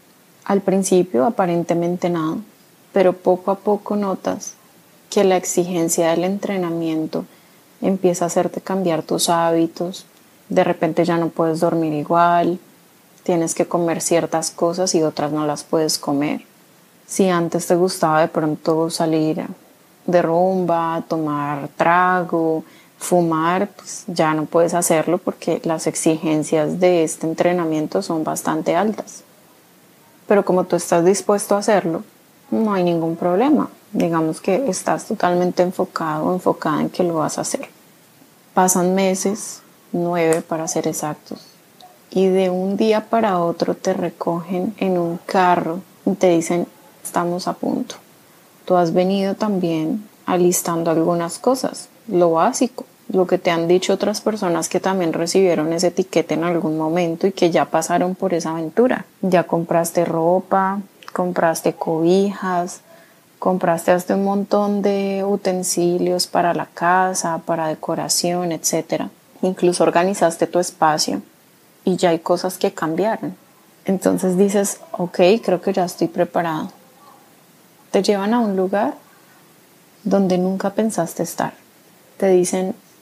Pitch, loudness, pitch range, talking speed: 175 Hz, -19 LUFS, 165-190 Hz, 135 wpm